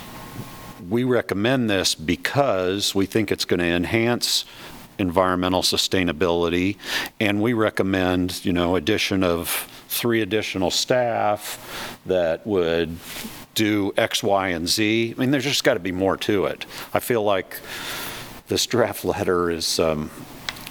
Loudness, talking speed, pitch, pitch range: -22 LUFS, 135 wpm, 95 Hz, 90-110 Hz